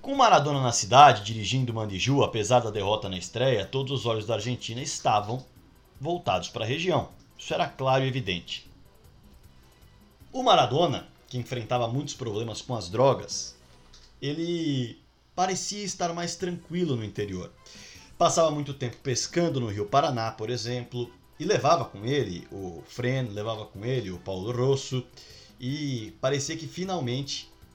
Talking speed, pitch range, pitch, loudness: 145 wpm, 110-140 Hz, 125 Hz, -27 LUFS